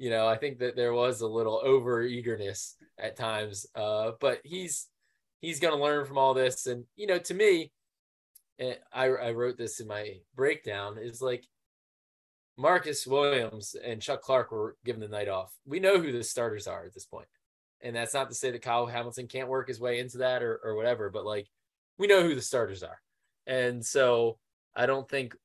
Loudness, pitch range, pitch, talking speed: -30 LUFS, 115-135 Hz, 125 Hz, 205 wpm